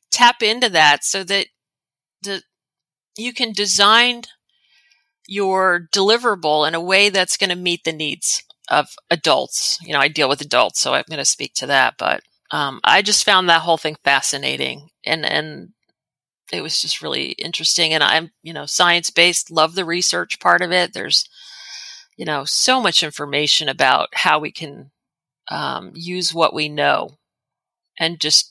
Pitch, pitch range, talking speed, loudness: 180 Hz, 160-210 Hz, 170 wpm, -16 LUFS